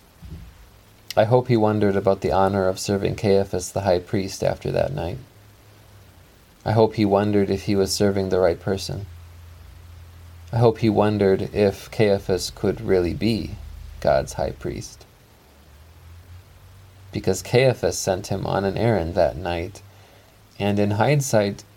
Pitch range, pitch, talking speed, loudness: 90-105 Hz, 100 Hz, 140 wpm, -22 LUFS